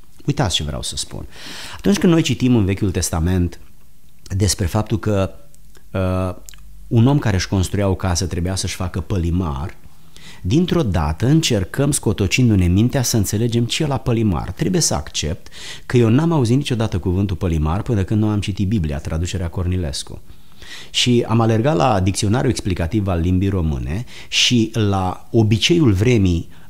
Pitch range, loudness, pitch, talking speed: 90-120 Hz, -18 LUFS, 100 Hz, 155 wpm